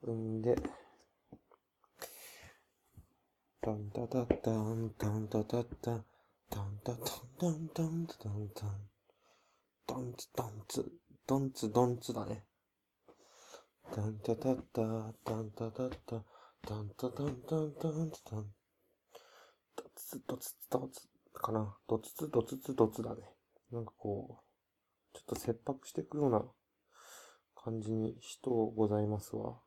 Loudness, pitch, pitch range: -39 LUFS, 115 Hz, 105-125 Hz